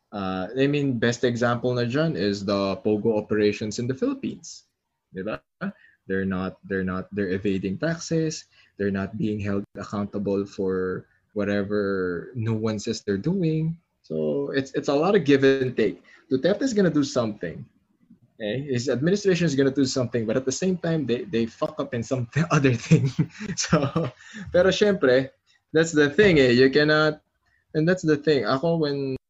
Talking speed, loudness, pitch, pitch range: 170 wpm, -24 LUFS, 130 Hz, 105-155 Hz